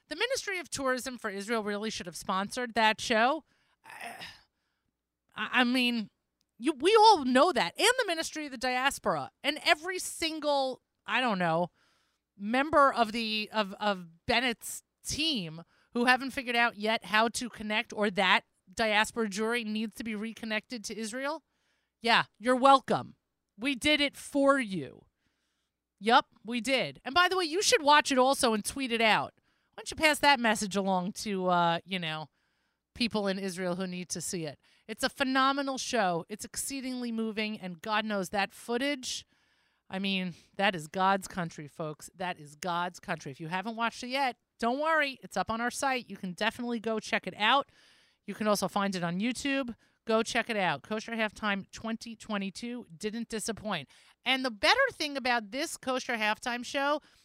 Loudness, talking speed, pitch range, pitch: -29 LUFS, 175 wpm, 200-265 Hz, 230 Hz